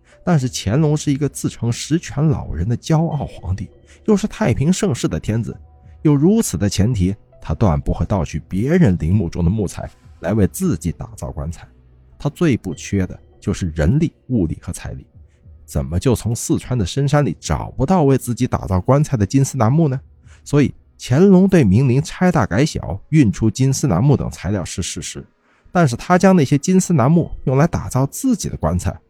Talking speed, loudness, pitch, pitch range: 285 characters per minute, -18 LUFS, 120 Hz, 95-150 Hz